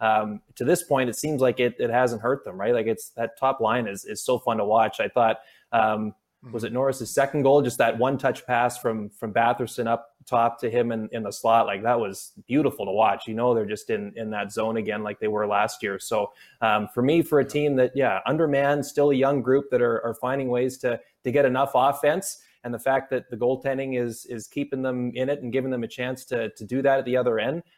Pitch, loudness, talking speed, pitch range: 125 Hz, -24 LUFS, 255 wpm, 115-135 Hz